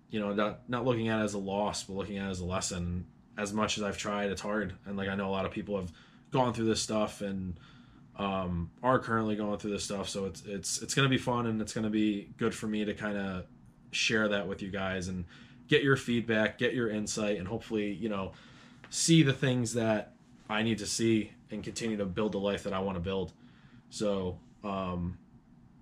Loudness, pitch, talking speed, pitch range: -32 LUFS, 105 Hz, 235 wpm, 100-115 Hz